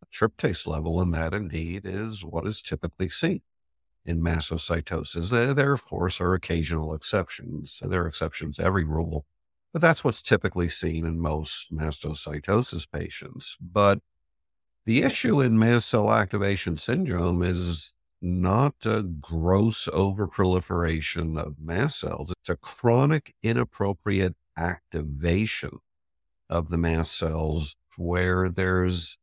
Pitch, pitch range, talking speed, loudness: 85 Hz, 80-100 Hz, 125 wpm, -26 LUFS